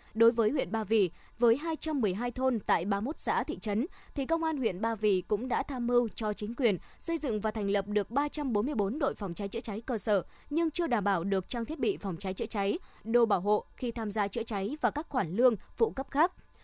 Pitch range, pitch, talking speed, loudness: 205-260 Hz, 230 Hz, 240 wpm, -31 LUFS